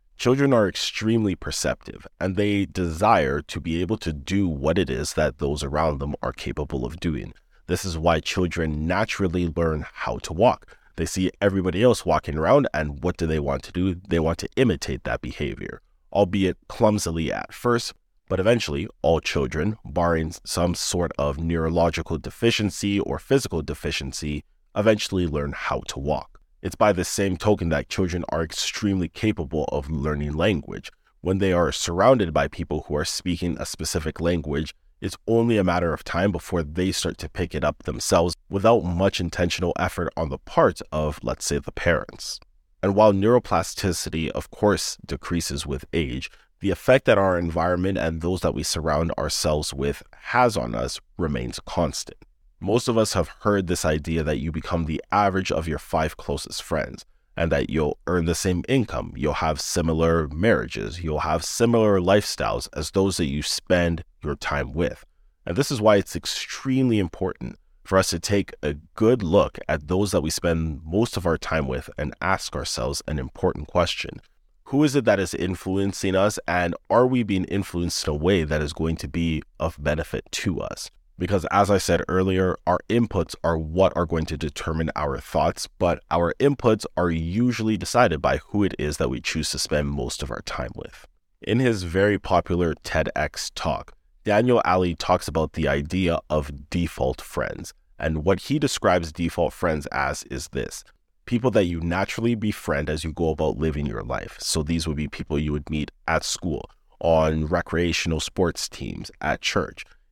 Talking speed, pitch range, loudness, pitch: 180 wpm, 75-95 Hz, -24 LUFS, 85 Hz